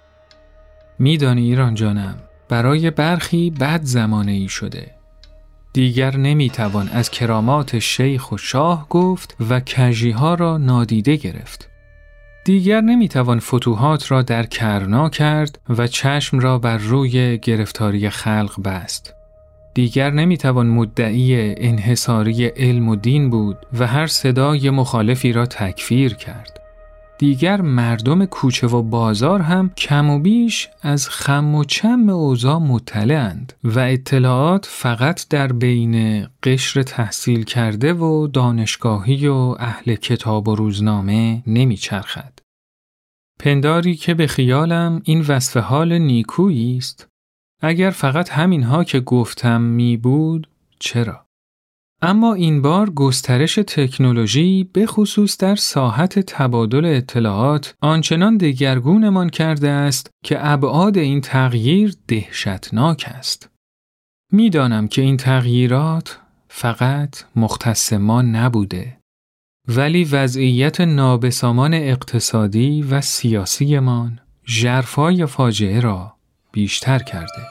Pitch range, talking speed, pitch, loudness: 115-150 Hz, 110 wpm, 130 Hz, -17 LUFS